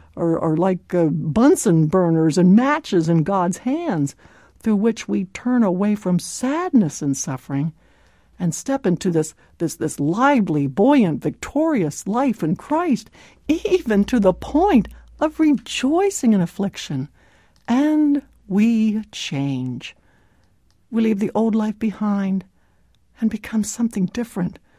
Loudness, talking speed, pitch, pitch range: -20 LUFS, 130 wpm, 200 Hz, 165-245 Hz